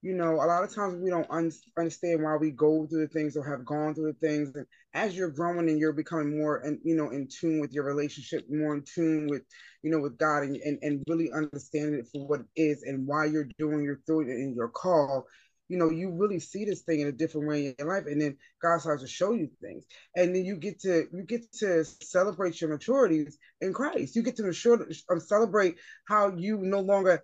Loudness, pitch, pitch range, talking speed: -29 LUFS, 160 Hz, 150-180 Hz, 240 wpm